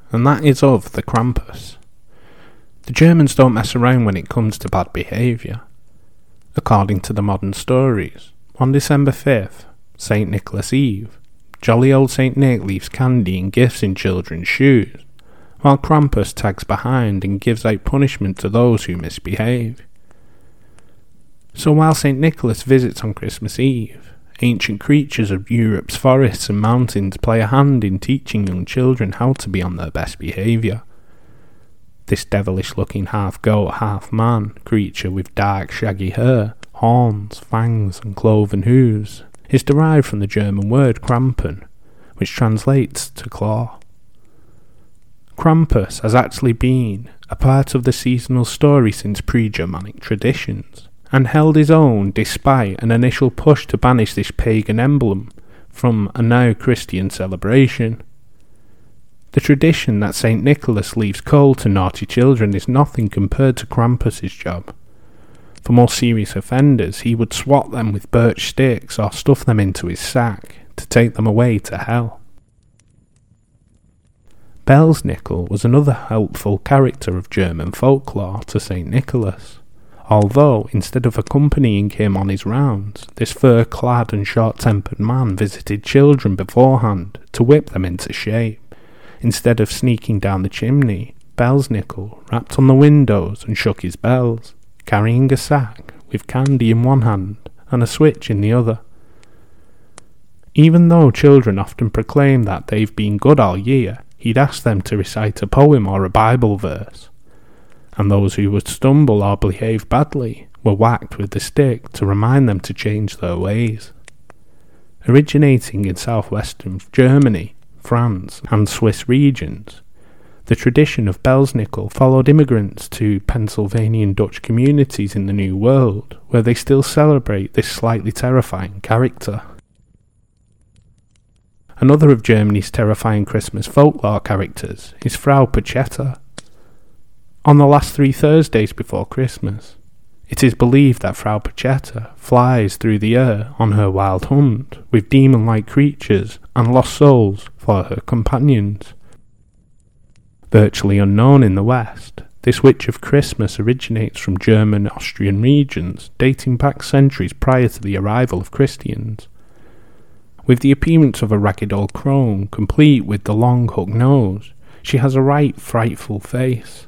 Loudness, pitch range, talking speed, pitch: -15 LUFS, 100-130 Hz, 140 wpm, 115 Hz